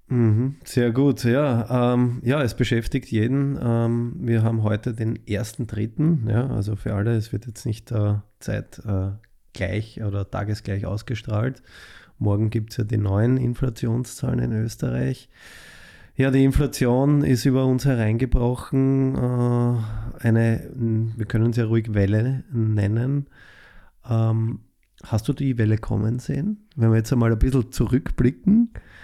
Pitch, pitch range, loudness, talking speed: 115 Hz, 110-130 Hz, -23 LUFS, 140 wpm